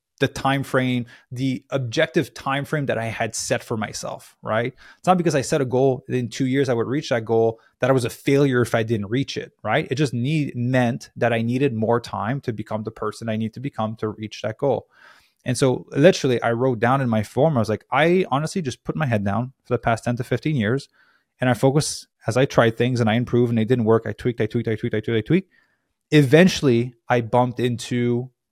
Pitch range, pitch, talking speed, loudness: 115-135 Hz, 125 Hz, 245 wpm, -22 LUFS